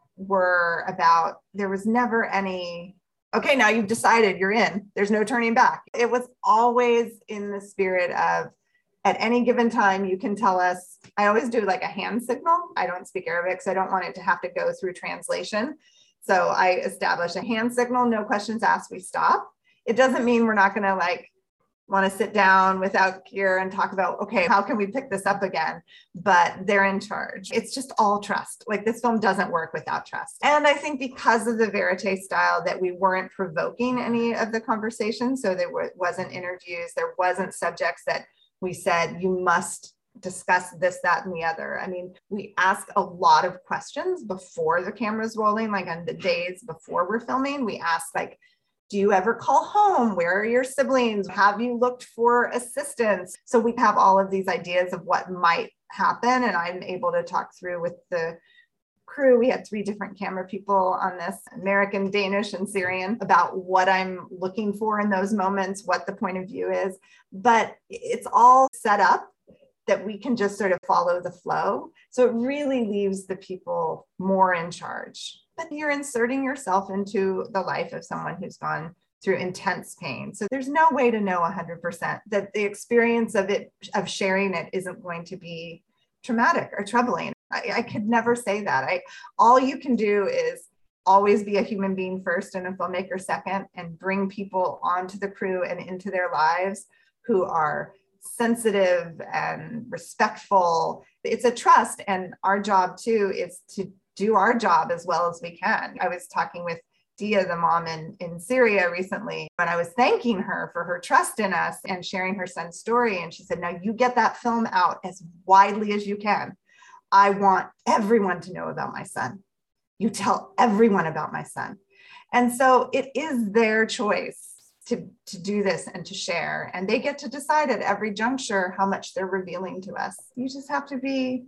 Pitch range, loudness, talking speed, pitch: 185-235 Hz, -24 LUFS, 190 wpm, 200 Hz